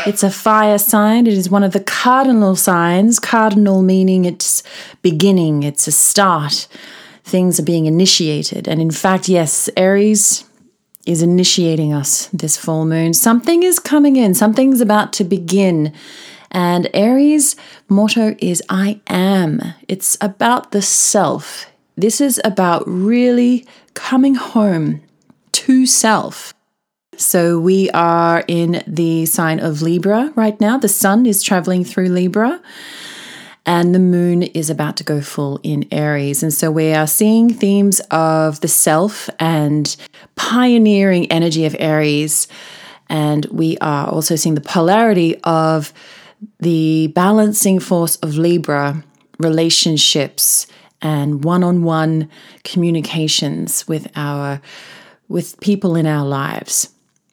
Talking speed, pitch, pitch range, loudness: 130 wpm, 180 Hz, 160-210 Hz, -14 LUFS